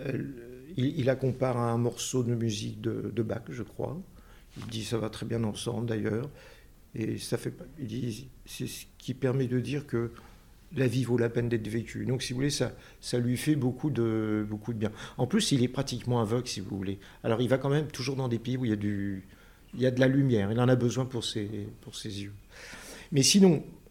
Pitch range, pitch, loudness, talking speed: 110-130 Hz, 120 Hz, -30 LUFS, 235 wpm